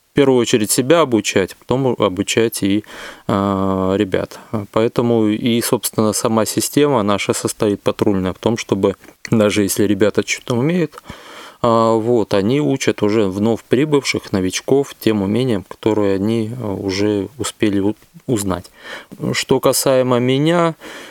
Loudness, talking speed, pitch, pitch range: -17 LUFS, 120 wpm, 110 Hz, 100-125 Hz